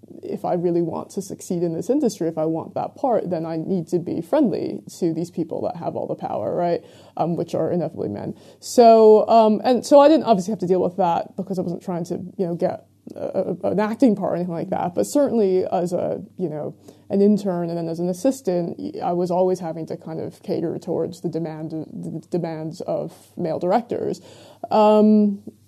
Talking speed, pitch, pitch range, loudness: 215 wpm, 185 Hz, 170-215 Hz, -21 LUFS